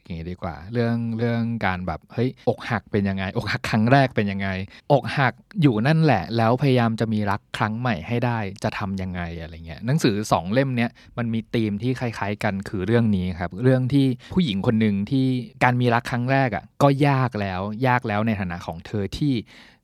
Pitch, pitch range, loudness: 115 Hz, 100-125 Hz, -23 LUFS